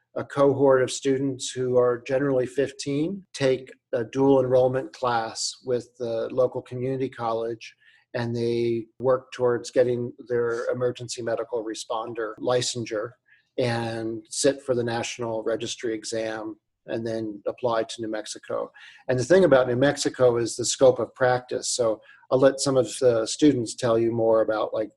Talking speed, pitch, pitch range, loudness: 155 wpm, 125 Hz, 115-130 Hz, -25 LUFS